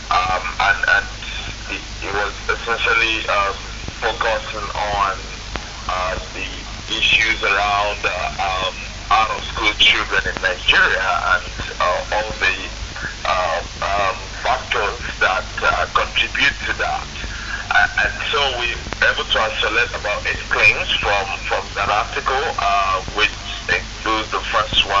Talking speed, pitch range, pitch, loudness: 125 wpm, 95-110 Hz, 105 Hz, -18 LUFS